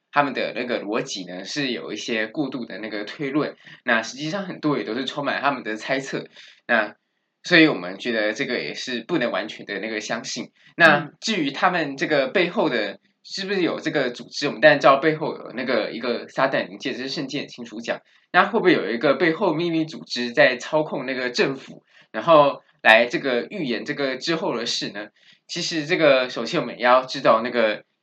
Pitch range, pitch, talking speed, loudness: 125-160 Hz, 145 Hz, 310 characters per minute, -22 LUFS